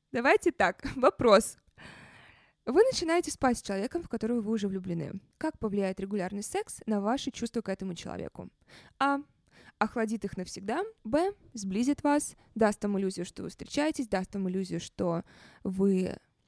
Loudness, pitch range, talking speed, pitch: -30 LUFS, 190-280 Hz, 150 wpm, 215 Hz